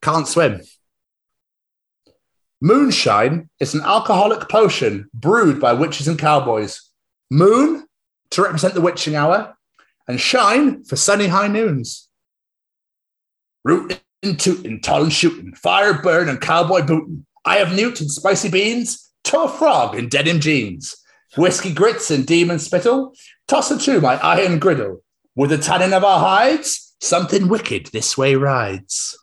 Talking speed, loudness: 140 wpm, -16 LUFS